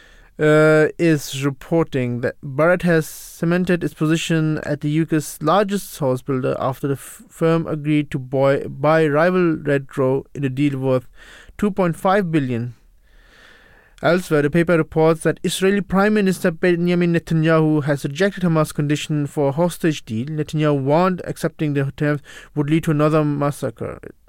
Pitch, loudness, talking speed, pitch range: 155 Hz, -19 LUFS, 145 wpm, 145-170 Hz